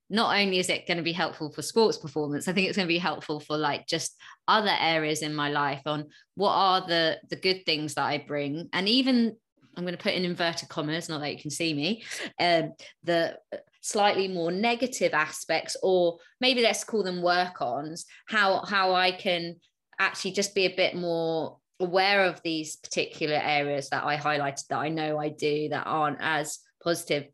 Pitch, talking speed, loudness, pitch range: 170 Hz, 200 wpm, -27 LUFS, 150-190 Hz